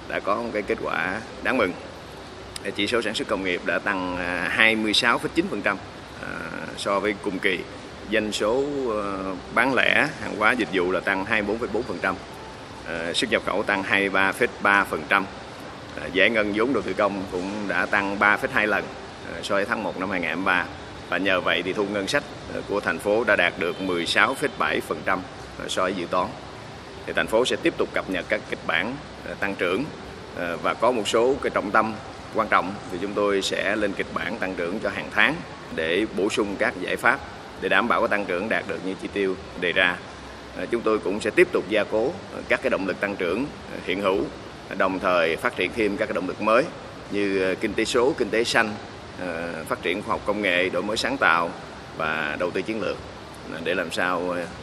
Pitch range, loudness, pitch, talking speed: 95-110 Hz, -24 LUFS, 100 Hz, 190 wpm